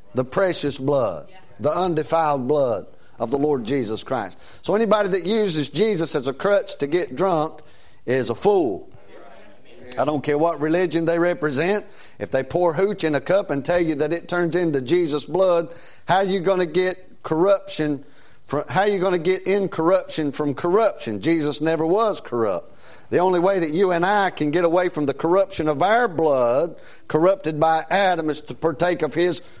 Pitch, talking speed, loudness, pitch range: 170 Hz, 180 wpm, -21 LUFS, 150-190 Hz